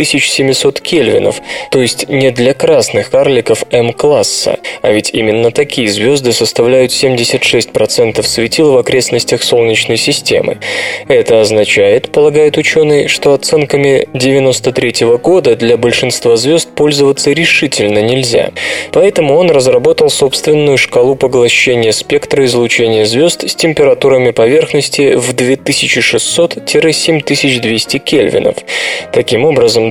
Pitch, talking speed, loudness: 165 Hz, 105 wpm, -9 LUFS